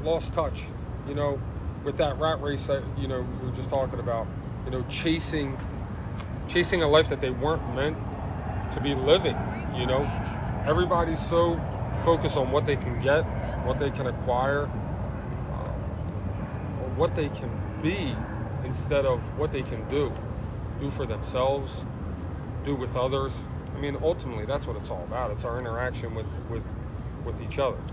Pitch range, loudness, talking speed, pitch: 110-135 Hz, -29 LUFS, 165 wpm, 125 Hz